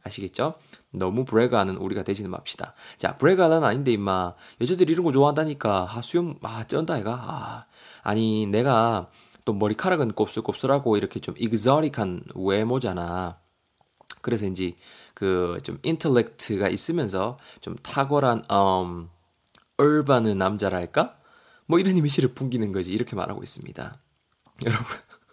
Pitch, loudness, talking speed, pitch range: 110 Hz, -24 LUFS, 315 characters per minute, 95-140 Hz